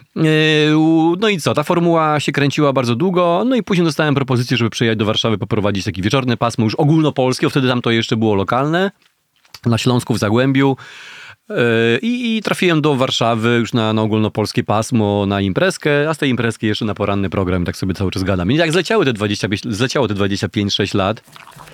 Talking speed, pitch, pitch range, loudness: 180 wpm, 125 Hz, 110-155 Hz, -16 LUFS